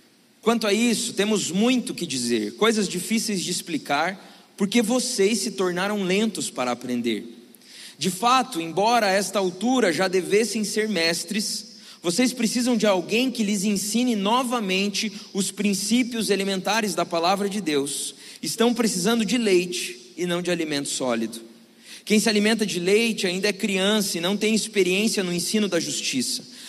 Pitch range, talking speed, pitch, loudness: 180-225 Hz, 155 wpm, 205 Hz, -23 LUFS